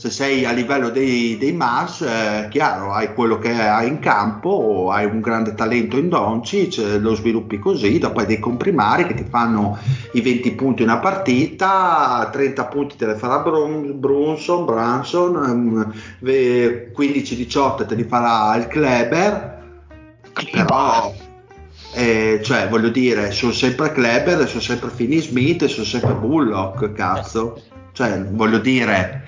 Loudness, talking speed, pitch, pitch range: -18 LUFS, 140 wpm, 120 Hz, 110-135 Hz